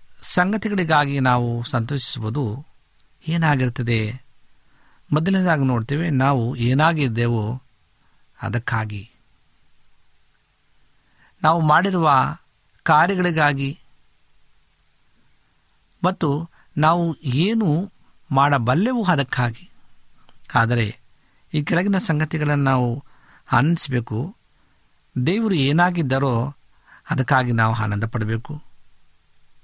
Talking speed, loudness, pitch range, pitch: 60 wpm, -20 LUFS, 120-160 Hz, 140 Hz